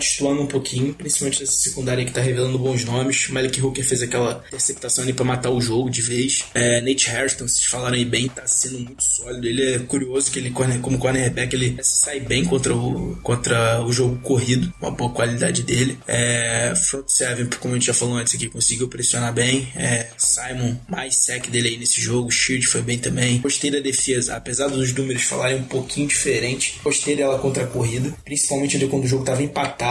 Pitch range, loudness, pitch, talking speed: 120-135 Hz, -20 LUFS, 130 Hz, 205 wpm